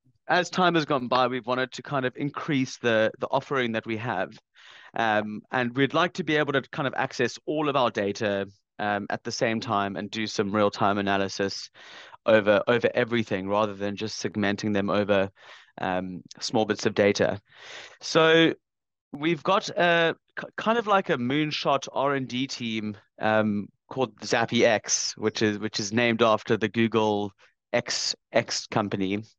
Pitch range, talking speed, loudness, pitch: 105-140 Hz, 175 wpm, -26 LUFS, 115 Hz